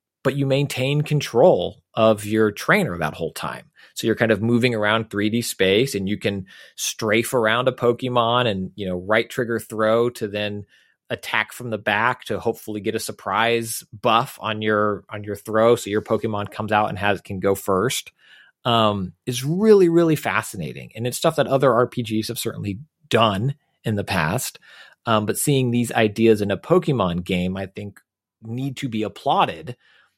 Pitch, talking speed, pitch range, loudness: 110 Hz, 180 wpm, 105-125 Hz, -21 LUFS